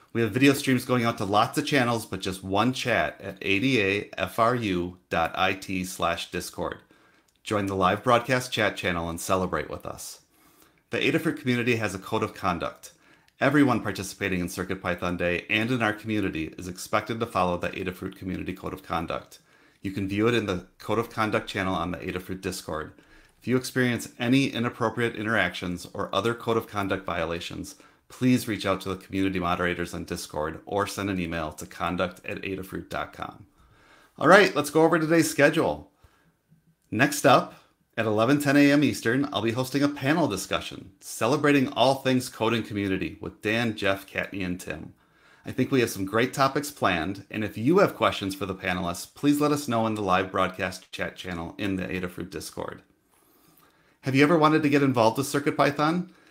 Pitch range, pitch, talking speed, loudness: 95-125 Hz, 105 Hz, 180 wpm, -26 LUFS